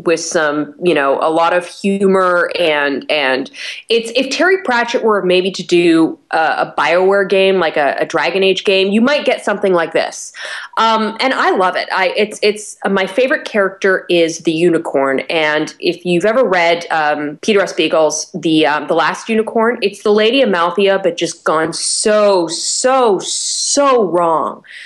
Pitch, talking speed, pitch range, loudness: 190 Hz, 180 wpm, 165-225 Hz, -14 LUFS